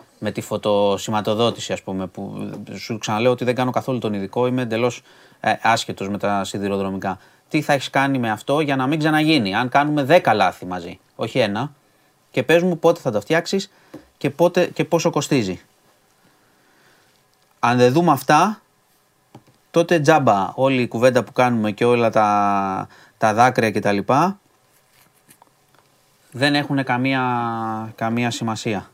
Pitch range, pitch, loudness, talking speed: 110-150 Hz, 125 Hz, -19 LUFS, 145 wpm